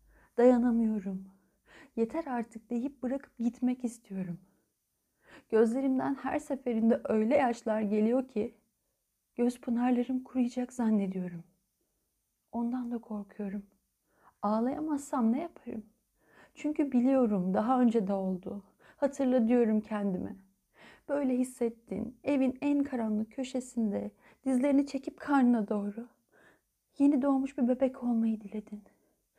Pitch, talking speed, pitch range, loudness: 240 Hz, 100 wpm, 215-265 Hz, -31 LUFS